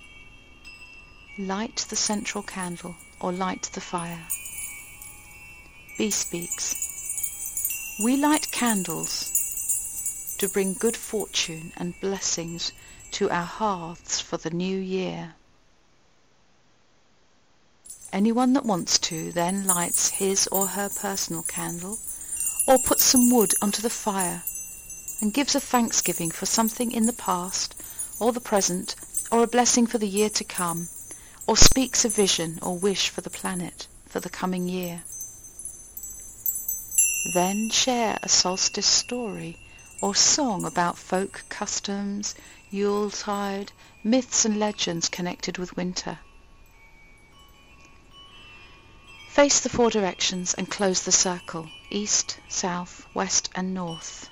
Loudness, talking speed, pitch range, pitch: -24 LUFS, 120 wpm, 160-210 Hz, 185 Hz